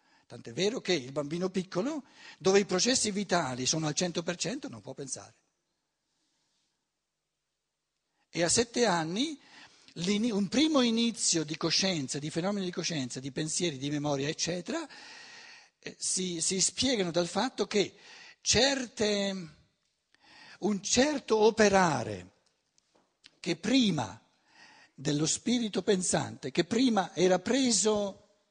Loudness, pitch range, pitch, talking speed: -29 LUFS, 165-230 Hz, 190 Hz, 110 wpm